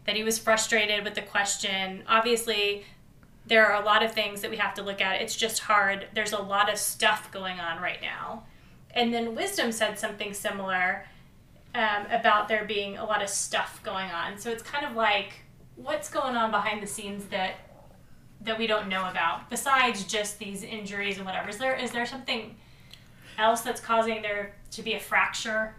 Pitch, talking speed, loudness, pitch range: 210 Hz, 195 wpm, -27 LUFS, 200-225 Hz